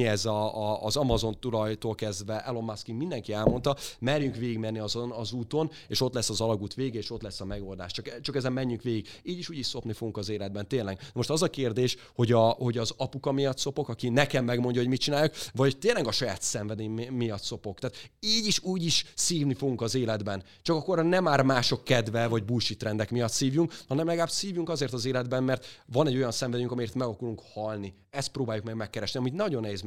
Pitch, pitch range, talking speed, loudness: 120 Hz, 110-135 Hz, 215 wpm, -29 LUFS